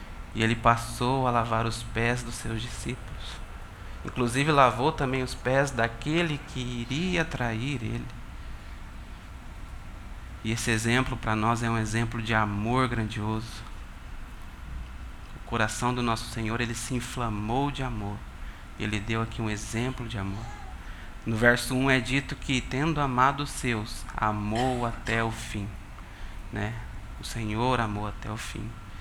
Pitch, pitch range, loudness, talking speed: 115 Hz, 105-125 Hz, -28 LUFS, 145 wpm